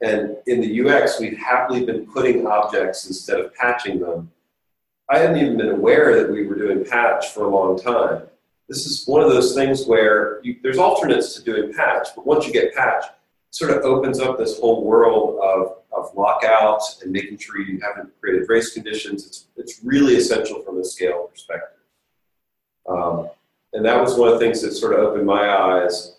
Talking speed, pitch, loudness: 195 wpm, 115 Hz, -18 LUFS